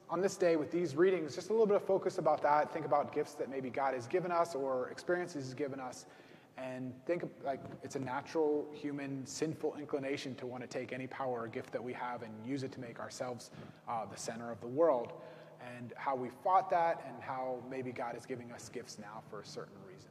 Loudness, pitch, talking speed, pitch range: -37 LUFS, 140 Hz, 235 wpm, 125-160 Hz